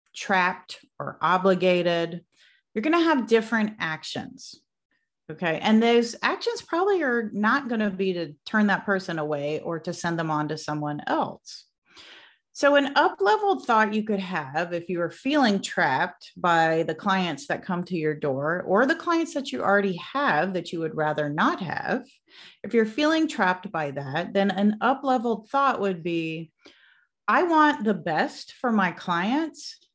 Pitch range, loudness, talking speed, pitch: 170-270 Hz, -24 LUFS, 170 wpm, 200 Hz